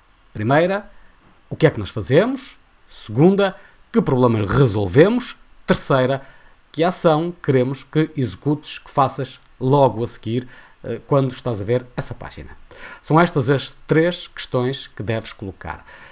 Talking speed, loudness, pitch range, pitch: 135 wpm, -19 LUFS, 120-160 Hz, 135 Hz